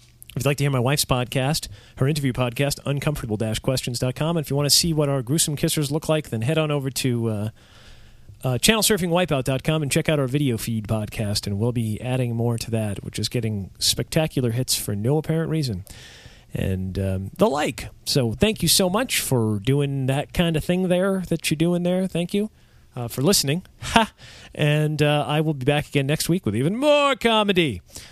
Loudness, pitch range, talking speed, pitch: -22 LUFS, 120-160 Hz, 205 wpm, 140 Hz